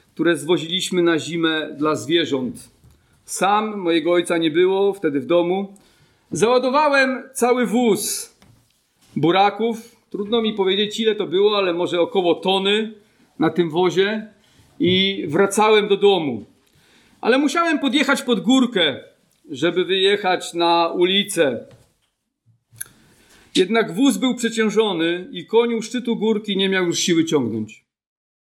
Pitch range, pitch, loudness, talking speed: 170-225 Hz, 195 Hz, -19 LUFS, 120 wpm